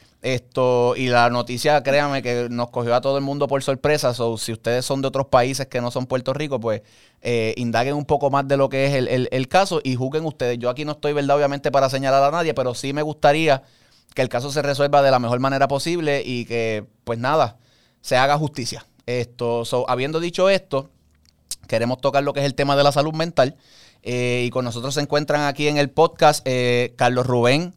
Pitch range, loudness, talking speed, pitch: 120-145 Hz, -20 LUFS, 225 wpm, 135 Hz